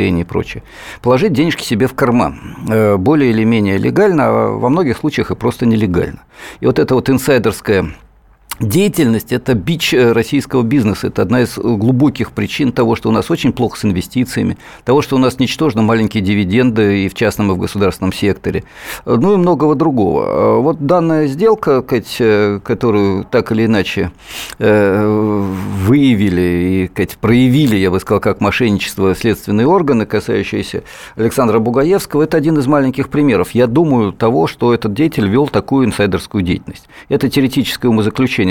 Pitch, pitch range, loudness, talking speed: 115 Hz, 105-135 Hz, -13 LUFS, 150 wpm